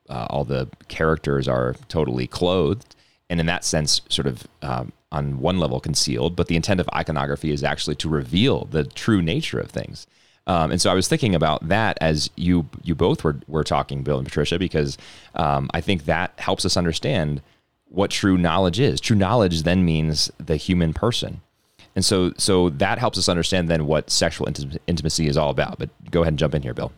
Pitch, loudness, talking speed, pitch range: 80 Hz, -22 LUFS, 200 wpm, 75-90 Hz